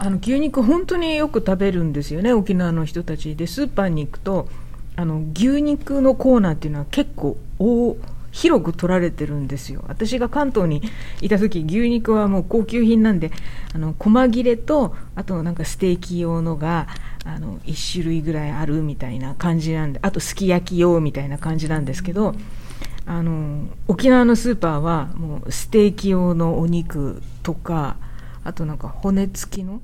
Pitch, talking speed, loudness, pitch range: 175 Hz, 320 characters per minute, -20 LUFS, 155-220 Hz